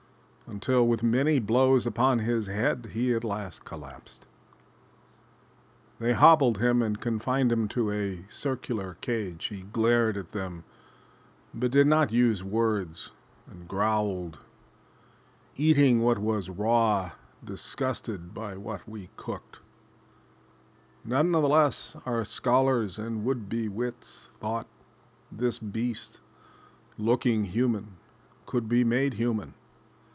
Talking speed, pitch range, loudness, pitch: 115 wpm, 105-125 Hz, -27 LUFS, 115 Hz